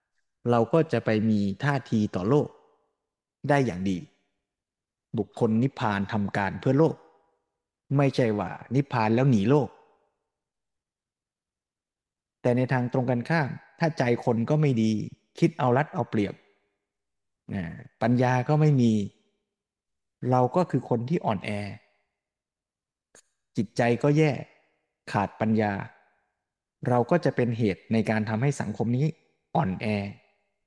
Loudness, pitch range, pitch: -26 LUFS, 105-140 Hz, 120 Hz